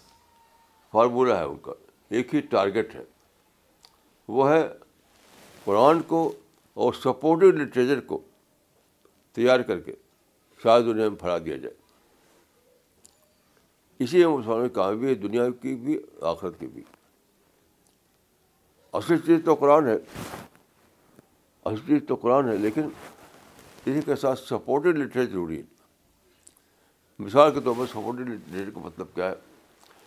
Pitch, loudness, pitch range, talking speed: 130 Hz, -24 LUFS, 115-155 Hz, 130 wpm